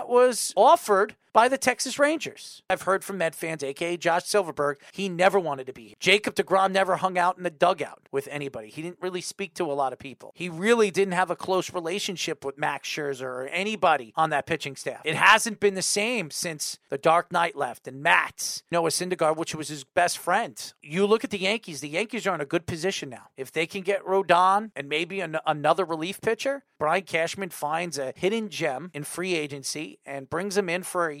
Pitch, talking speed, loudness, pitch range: 175 Hz, 215 wpm, -25 LUFS, 155-195 Hz